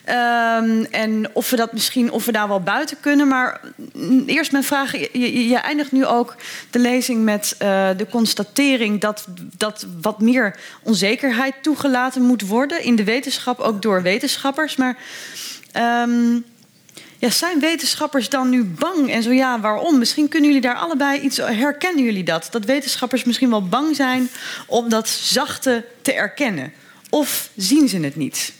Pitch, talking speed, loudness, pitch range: 245 Hz, 170 wpm, -18 LUFS, 220-275 Hz